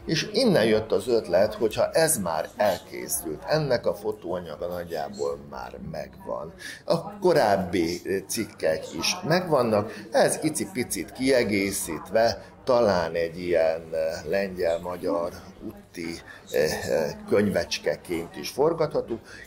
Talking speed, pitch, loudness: 95 wpm, 105 Hz, -26 LUFS